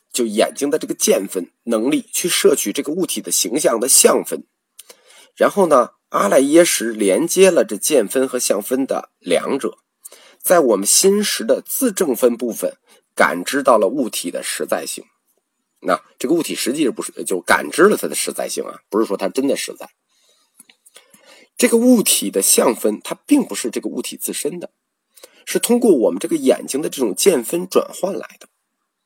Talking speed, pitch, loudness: 260 characters per minute, 230 Hz, -17 LUFS